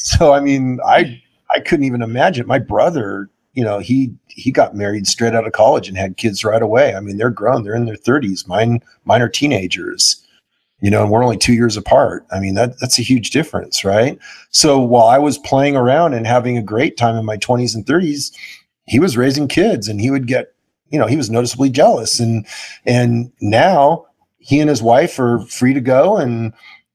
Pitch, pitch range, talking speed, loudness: 120 Hz, 110-130 Hz, 210 wpm, -14 LUFS